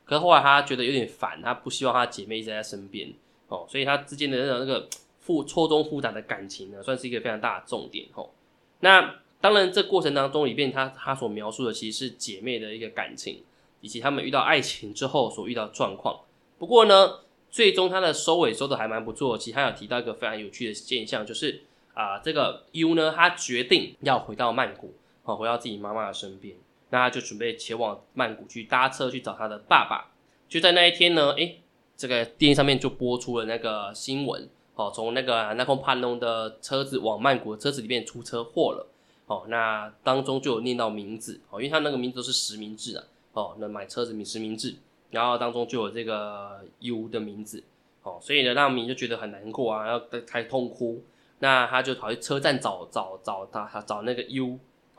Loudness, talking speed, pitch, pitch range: -25 LUFS, 320 characters per minute, 125 Hz, 110-135 Hz